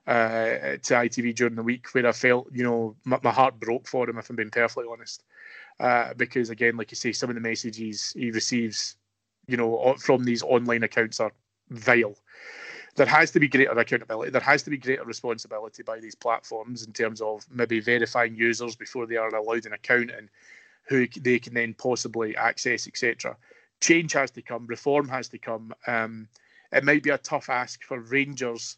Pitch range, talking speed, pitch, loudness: 115-125 Hz, 195 wpm, 120 Hz, -25 LUFS